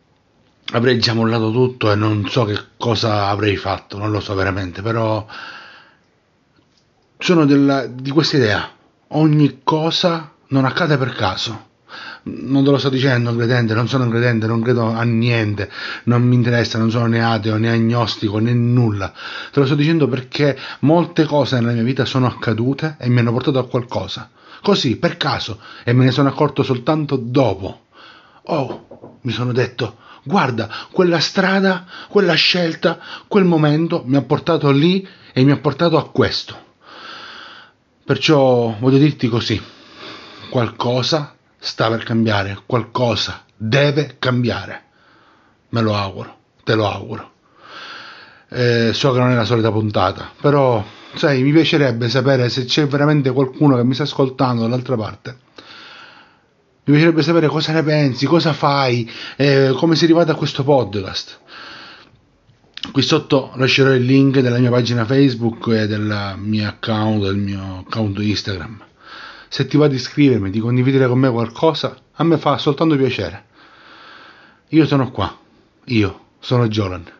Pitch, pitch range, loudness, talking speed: 125 Hz, 115-145 Hz, -17 LUFS, 150 wpm